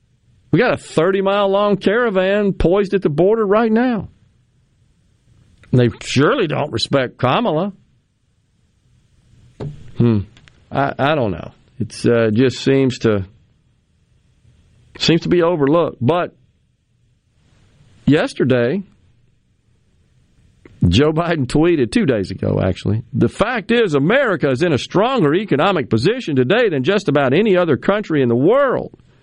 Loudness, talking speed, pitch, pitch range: -16 LUFS, 125 wpm, 135 Hz, 115-185 Hz